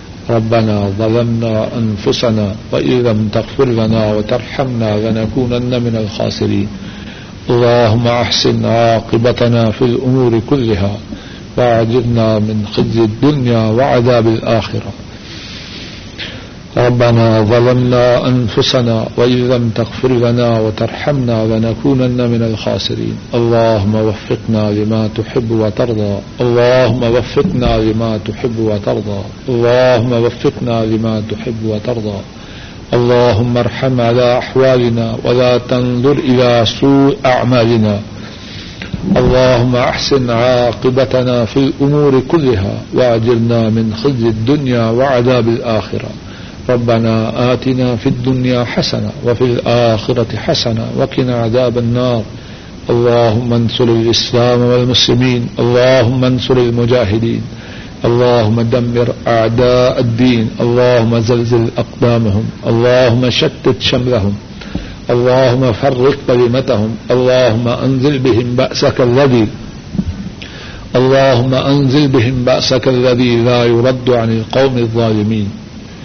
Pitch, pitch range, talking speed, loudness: 120 Hz, 110-125 Hz, 95 wpm, -12 LUFS